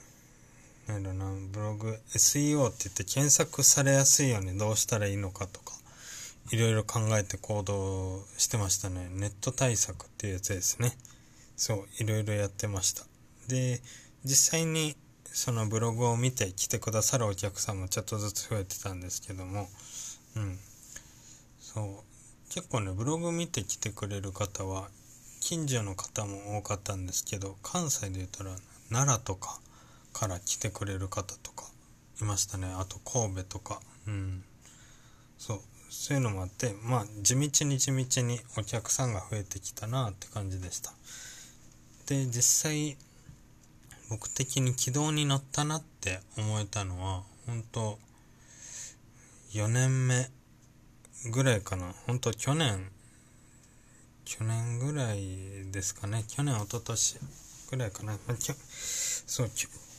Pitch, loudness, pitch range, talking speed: 110 Hz, -31 LUFS, 100-125 Hz, 270 characters per minute